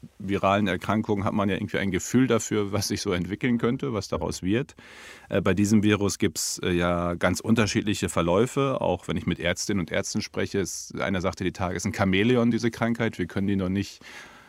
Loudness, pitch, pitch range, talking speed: -25 LUFS, 100 Hz, 95-110 Hz, 210 wpm